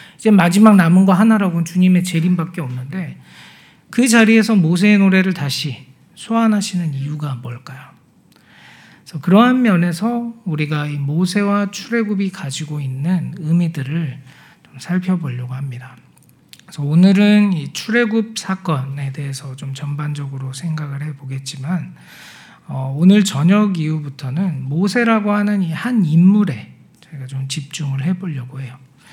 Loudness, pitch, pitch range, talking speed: -16 LUFS, 170 Hz, 140-195 Hz, 305 characters per minute